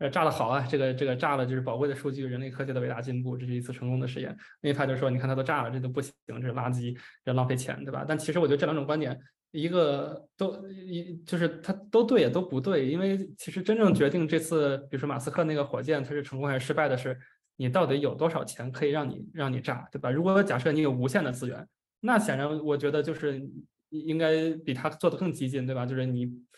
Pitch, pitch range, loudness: 145 Hz, 130-160 Hz, -29 LUFS